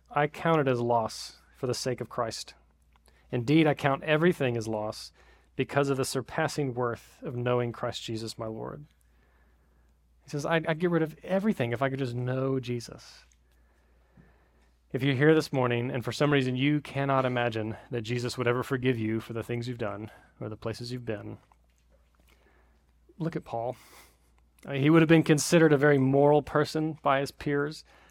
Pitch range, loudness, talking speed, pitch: 100-145 Hz, -28 LUFS, 180 wpm, 125 Hz